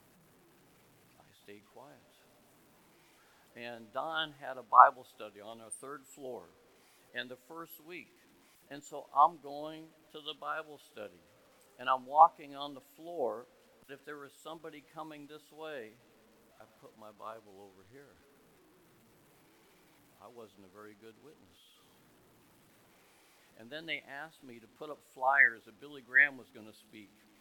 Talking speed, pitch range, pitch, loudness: 140 wpm, 110-150 Hz, 130 Hz, -31 LUFS